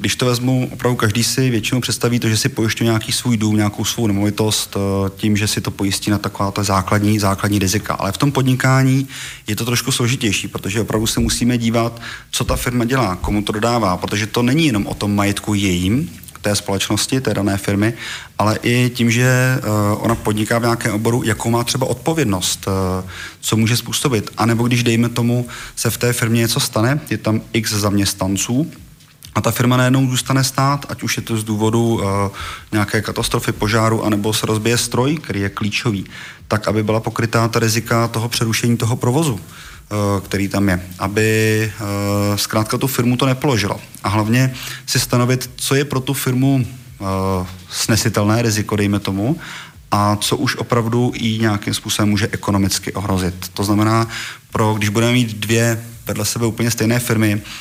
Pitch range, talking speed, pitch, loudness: 105-120 Hz, 180 wpm, 115 Hz, -17 LUFS